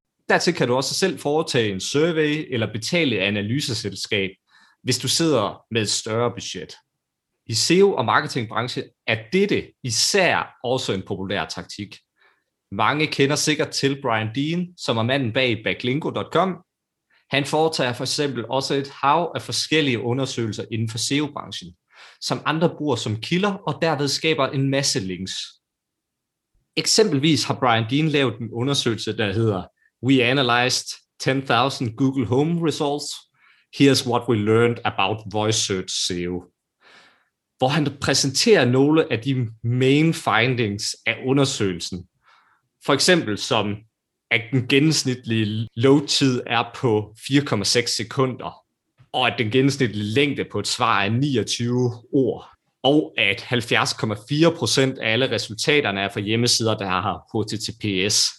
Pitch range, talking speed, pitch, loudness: 110-140 Hz, 135 wpm, 125 Hz, -21 LUFS